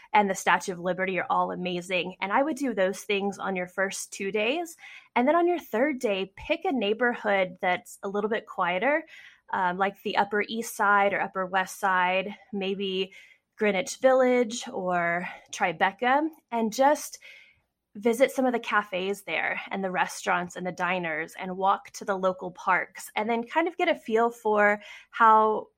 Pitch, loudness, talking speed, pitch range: 205 Hz, -26 LUFS, 180 wpm, 185-250 Hz